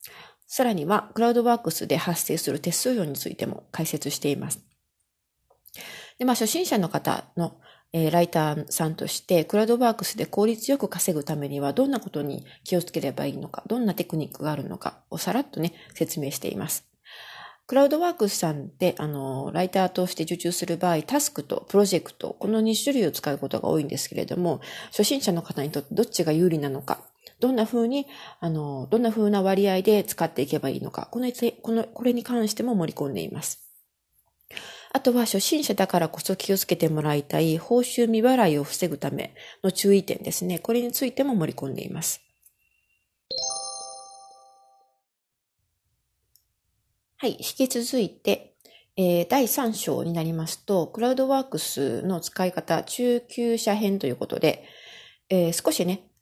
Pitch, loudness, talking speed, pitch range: 185 Hz, -25 LUFS, 350 characters per minute, 160-235 Hz